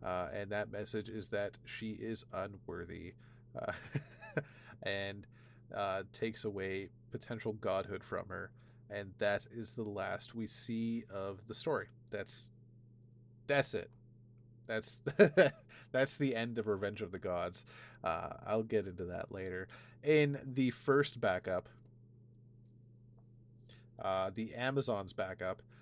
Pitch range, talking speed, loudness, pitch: 105-120 Hz, 125 wpm, -38 LUFS, 115 Hz